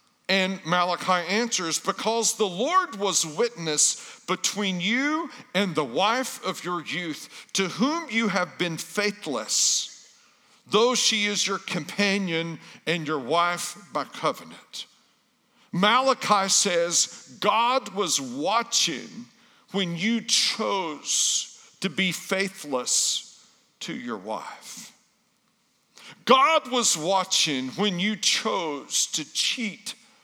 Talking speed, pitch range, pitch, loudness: 105 wpm, 175-235 Hz, 200 Hz, -24 LUFS